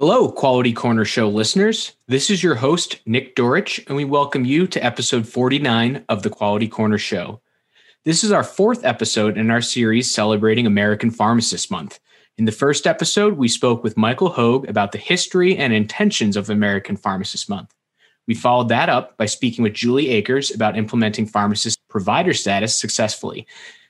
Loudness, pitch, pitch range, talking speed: -18 LUFS, 120 Hz, 110-140 Hz, 170 wpm